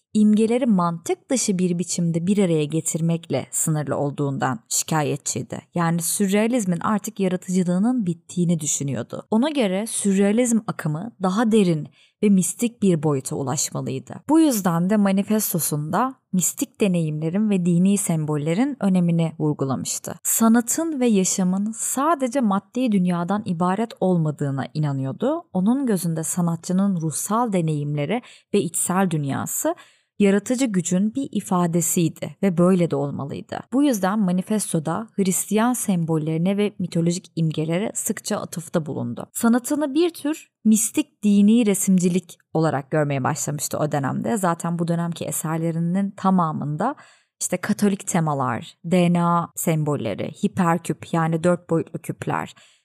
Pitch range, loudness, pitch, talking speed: 165-215 Hz, -22 LUFS, 185 Hz, 115 wpm